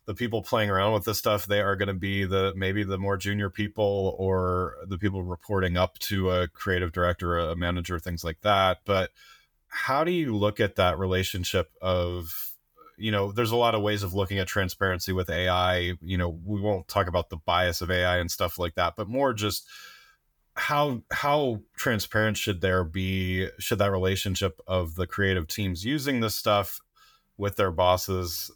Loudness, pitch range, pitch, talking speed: -27 LUFS, 90-105 Hz, 95 Hz, 190 wpm